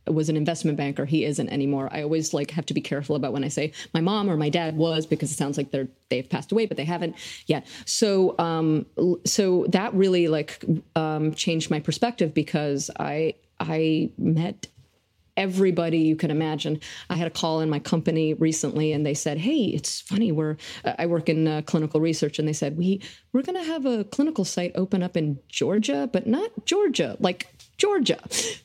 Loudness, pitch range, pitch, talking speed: -25 LUFS, 155-185 Hz, 160 Hz, 200 wpm